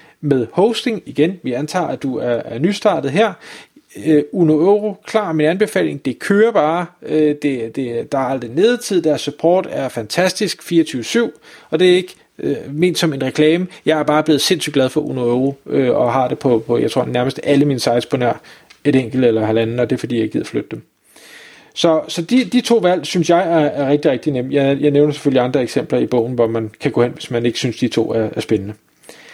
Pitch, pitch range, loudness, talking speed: 145 Hz, 125-170 Hz, -17 LUFS, 225 wpm